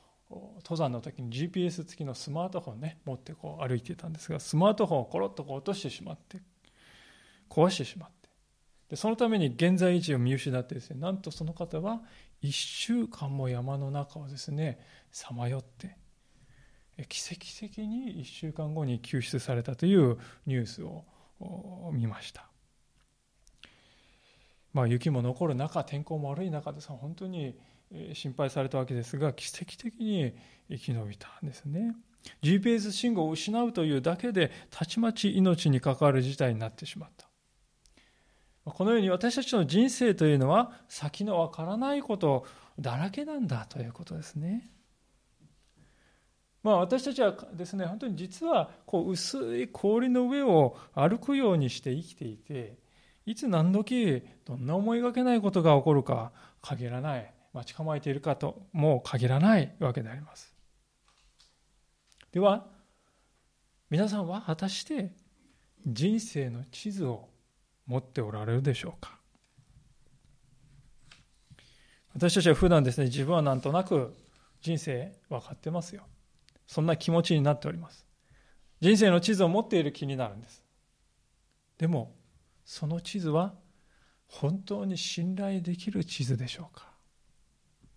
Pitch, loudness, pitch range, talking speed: 160 Hz, -30 LUFS, 135-190 Hz, 285 characters per minute